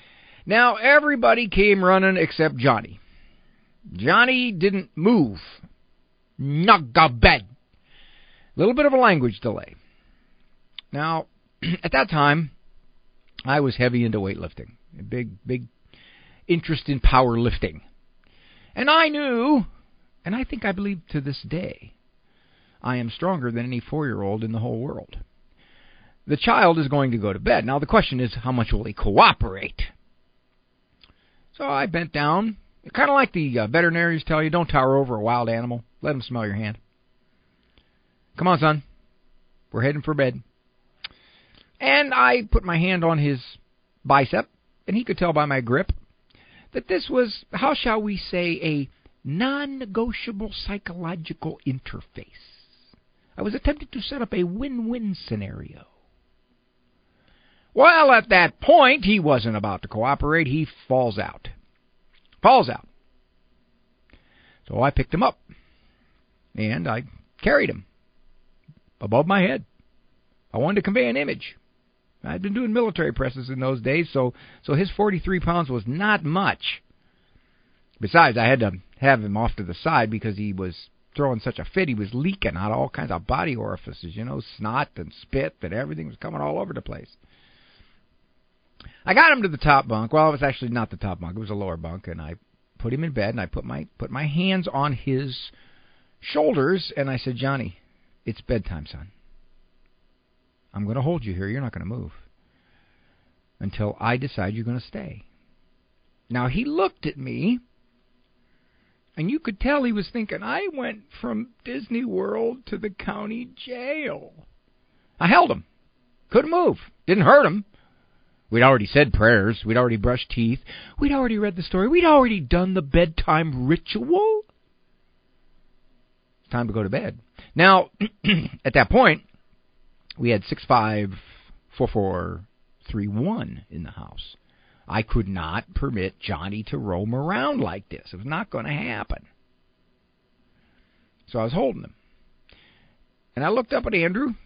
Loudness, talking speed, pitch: -22 LUFS, 155 wpm, 130 Hz